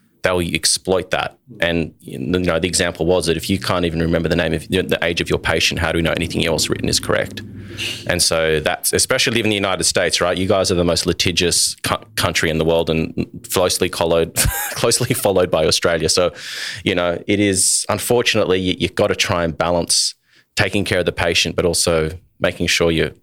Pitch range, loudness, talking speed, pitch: 80-95 Hz, -17 LUFS, 215 wpm, 90 Hz